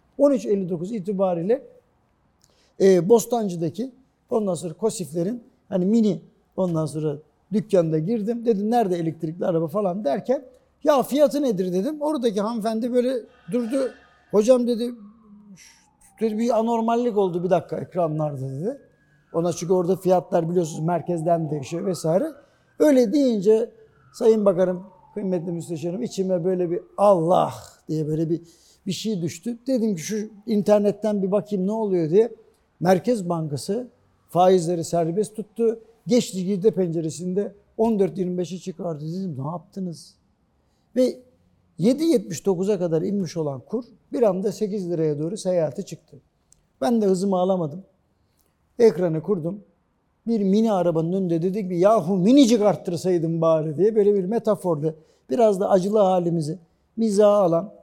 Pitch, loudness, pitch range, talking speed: 195 Hz, -22 LUFS, 175-225 Hz, 125 wpm